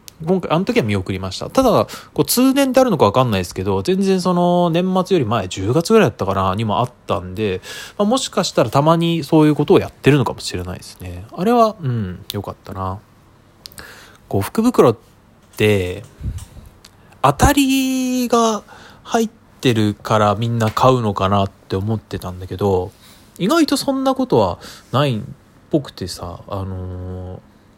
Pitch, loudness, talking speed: 115 Hz, -17 LUFS, 330 characters per minute